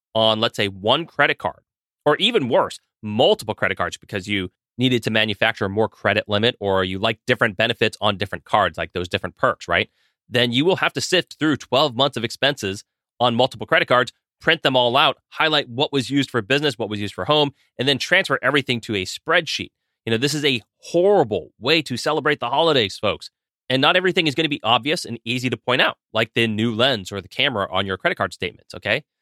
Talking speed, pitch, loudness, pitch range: 220 wpm, 120 Hz, -20 LUFS, 110-140 Hz